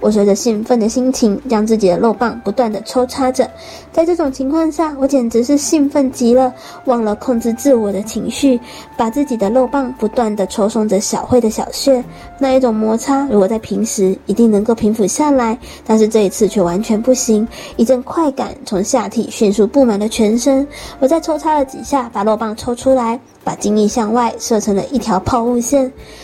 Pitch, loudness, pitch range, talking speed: 235 Hz, -15 LUFS, 215-265 Hz, 295 characters per minute